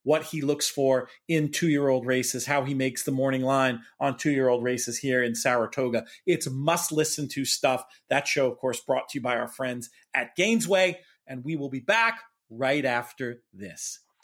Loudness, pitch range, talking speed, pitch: -26 LUFS, 125-155 Hz, 200 wpm, 135 Hz